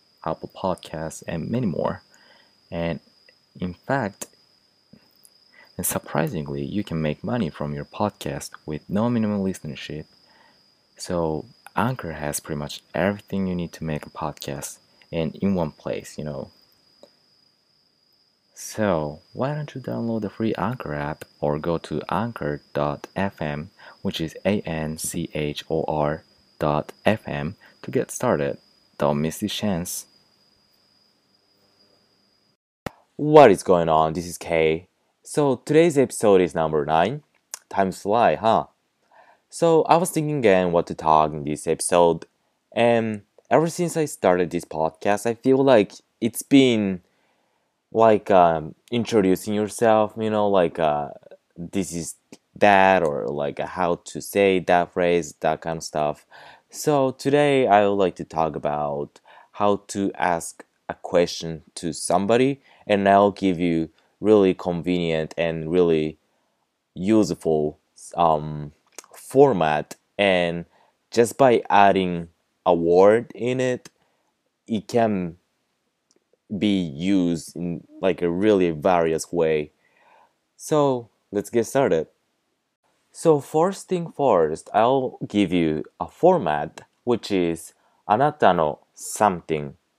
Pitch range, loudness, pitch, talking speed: 80-105 Hz, -22 LUFS, 90 Hz, 125 wpm